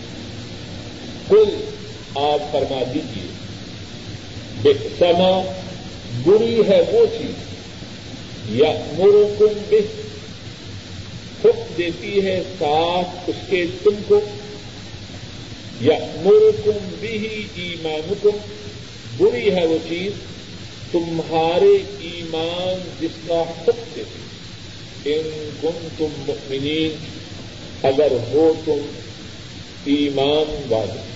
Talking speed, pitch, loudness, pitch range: 85 wpm, 160 Hz, -19 LUFS, 135-205 Hz